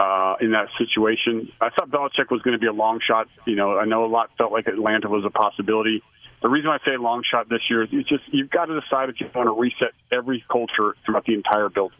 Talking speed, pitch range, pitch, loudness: 265 wpm, 110-125 Hz, 115 Hz, -22 LUFS